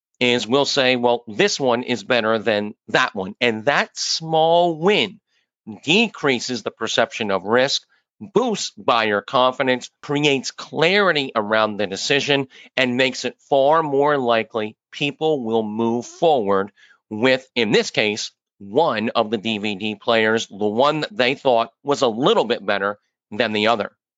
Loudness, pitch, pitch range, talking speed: -19 LUFS, 125 Hz, 110-140 Hz, 150 wpm